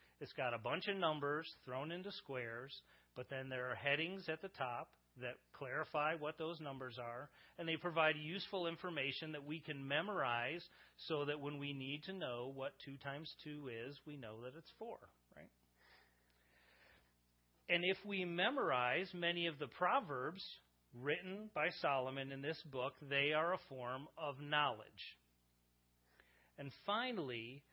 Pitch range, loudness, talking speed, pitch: 125-160 Hz, -42 LUFS, 155 wpm, 140 Hz